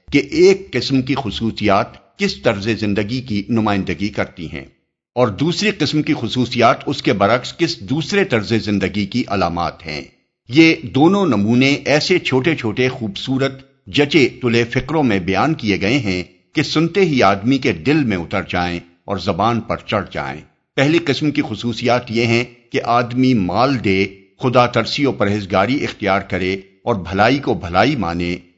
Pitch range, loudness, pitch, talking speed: 100-135 Hz, -17 LUFS, 120 Hz, 160 wpm